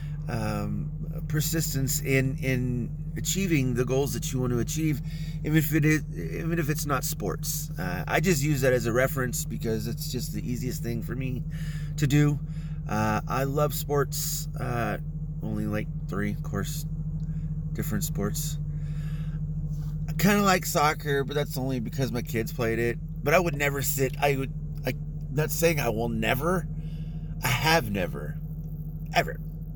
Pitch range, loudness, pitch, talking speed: 140-155 Hz, -28 LUFS, 155 Hz, 165 wpm